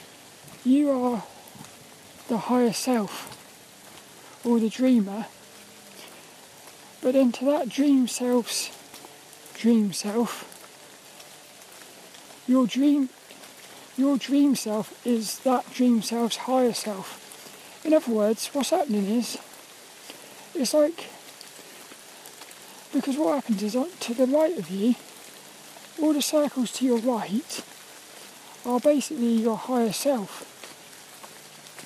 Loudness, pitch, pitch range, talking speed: -25 LUFS, 250 Hz, 230-275 Hz, 100 wpm